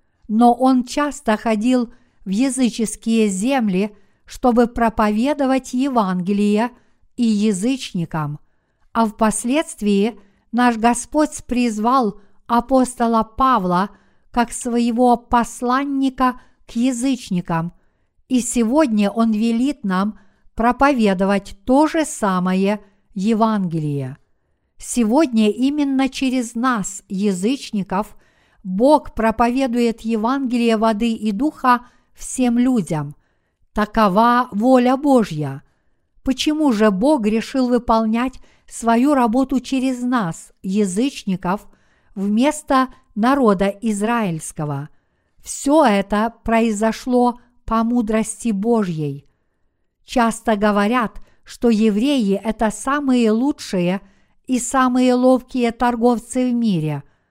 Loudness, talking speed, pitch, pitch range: -18 LUFS, 85 wpm, 230 Hz, 210-255 Hz